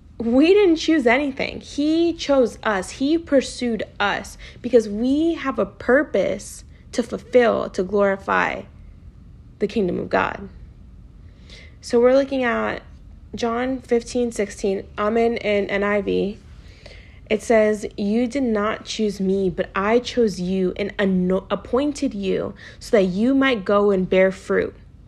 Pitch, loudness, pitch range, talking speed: 225 Hz, -21 LUFS, 200-255 Hz, 135 wpm